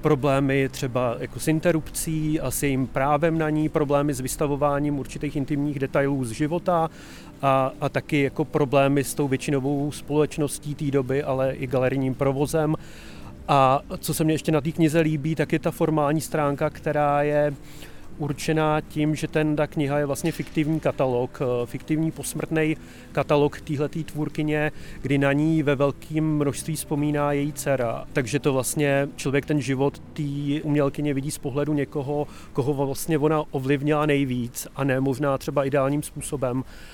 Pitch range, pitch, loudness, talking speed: 140-155 Hz, 145 Hz, -24 LUFS, 160 wpm